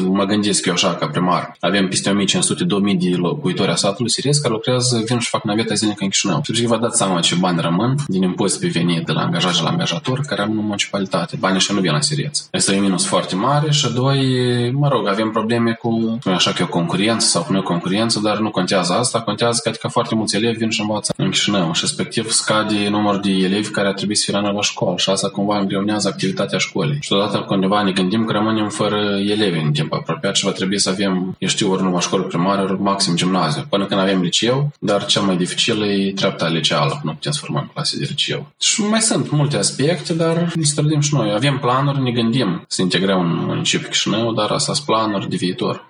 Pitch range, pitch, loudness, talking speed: 100-120 Hz, 105 Hz, -18 LUFS, 230 wpm